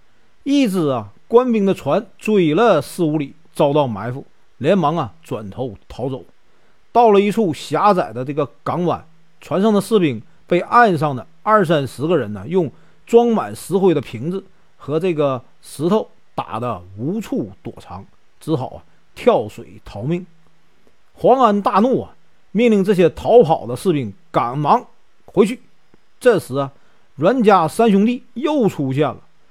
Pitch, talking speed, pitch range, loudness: 165 Hz, 215 characters per minute, 135-205 Hz, -17 LUFS